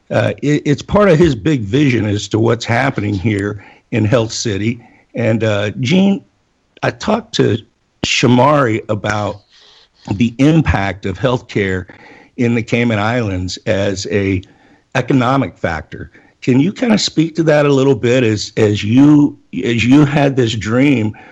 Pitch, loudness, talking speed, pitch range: 120 Hz, -14 LUFS, 150 wpm, 105-140 Hz